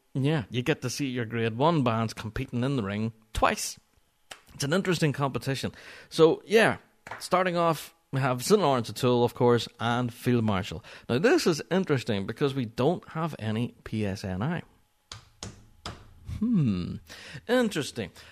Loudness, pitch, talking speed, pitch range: -27 LUFS, 125 Hz, 145 wpm, 110-150 Hz